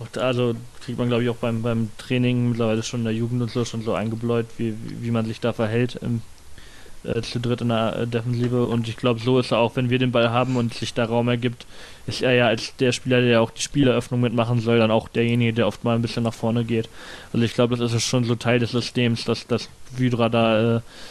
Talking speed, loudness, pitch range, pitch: 255 wpm, -22 LUFS, 115-120 Hz, 120 Hz